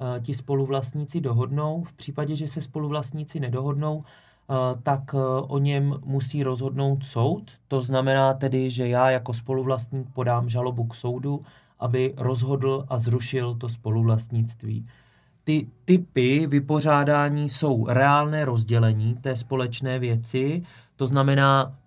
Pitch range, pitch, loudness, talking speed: 125-145 Hz, 135 Hz, -25 LUFS, 120 wpm